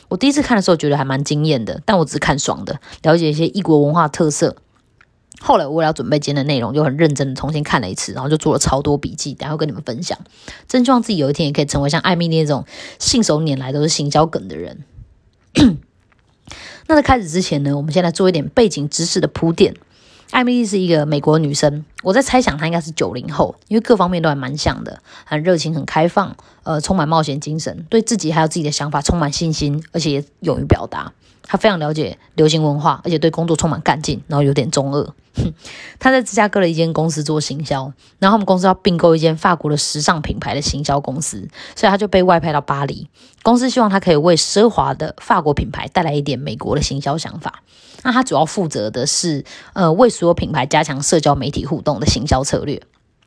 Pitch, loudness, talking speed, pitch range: 160 Hz, -16 LUFS, 350 characters per minute, 145-185 Hz